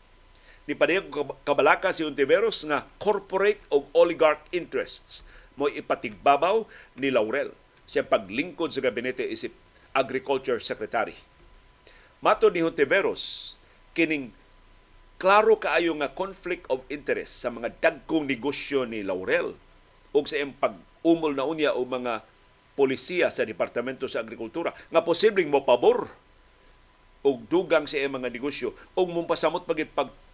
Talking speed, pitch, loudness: 125 wpm, 165 Hz, -26 LUFS